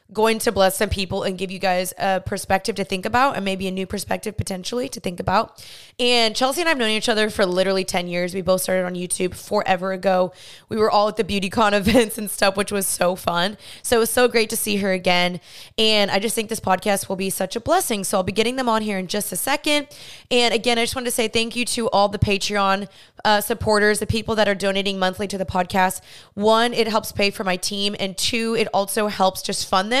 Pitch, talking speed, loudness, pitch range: 205 Hz, 250 wpm, -21 LUFS, 190-225 Hz